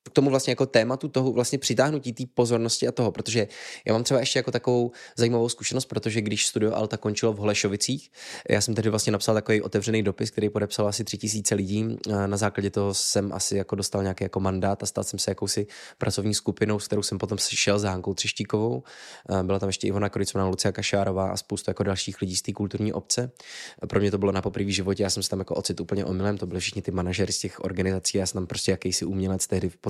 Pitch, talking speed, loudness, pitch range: 105 Hz, 230 wpm, -26 LUFS, 100-110 Hz